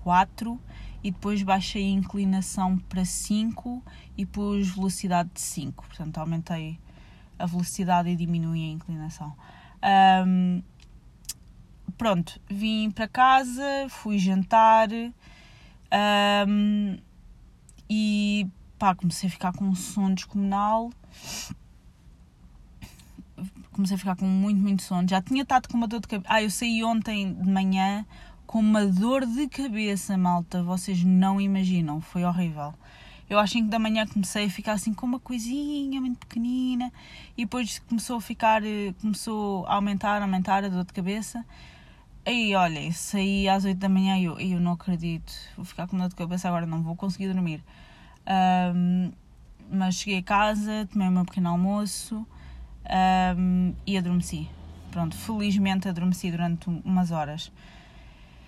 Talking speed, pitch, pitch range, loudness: 145 wpm, 190 Hz, 180-215 Hz, -26 LUFS